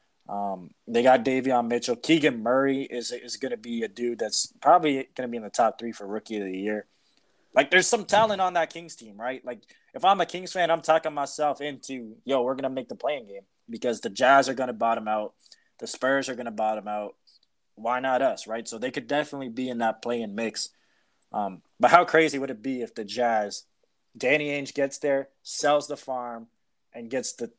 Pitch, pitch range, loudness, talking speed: 130 Hz, 115-150 Hz, -26 LUFS, 215 wpm